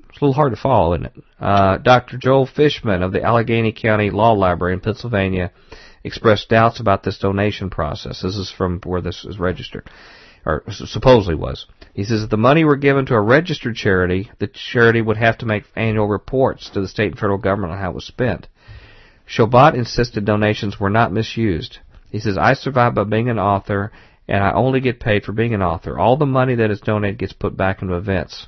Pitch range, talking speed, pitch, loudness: 95-120 Hz, 210 wpm, 105 Hz, -18 LUFS